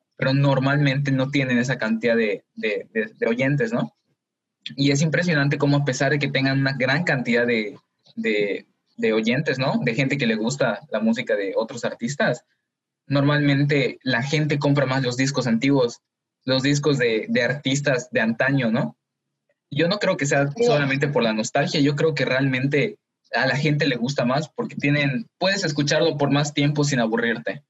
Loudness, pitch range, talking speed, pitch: -22 LUFS, 130-145 Hz, 180 wpm, 140 Hz